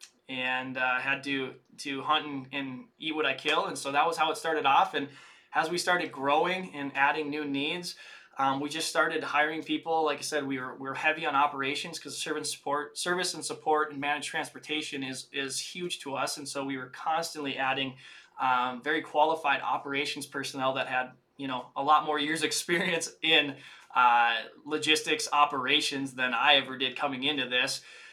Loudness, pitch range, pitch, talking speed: -29 LUFS, 135-155 Hz, 145 Hz, 190 wpm